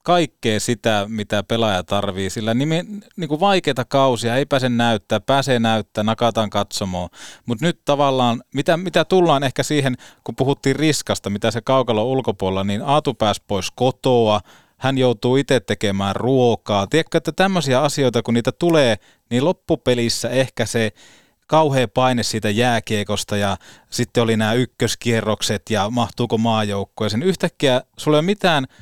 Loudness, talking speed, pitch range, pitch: -19 LUFS, 150 wpm, 110-140 Hz, 120 Hz